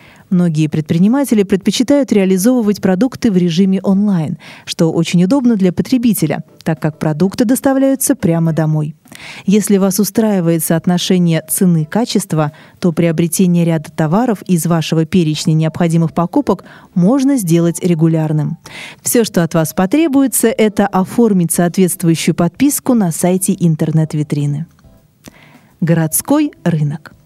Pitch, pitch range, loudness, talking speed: 180 Hz, 165-210 Hz, -14 LUFS, 110 wpm